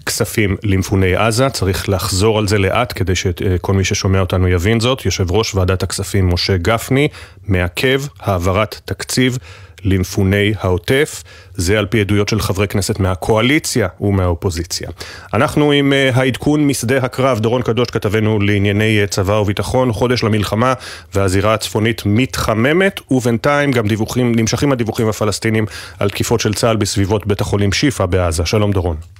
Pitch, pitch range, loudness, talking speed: 105 Hz, 95-120 Hz, -15 LUFS, 140 wpm